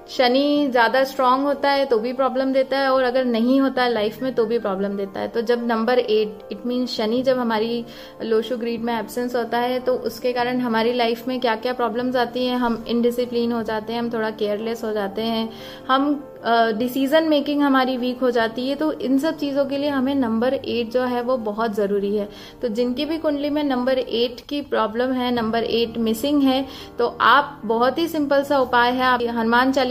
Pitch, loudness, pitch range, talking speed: 245 Hz, -21 LUFS, 230-265 Hz, 215 wpm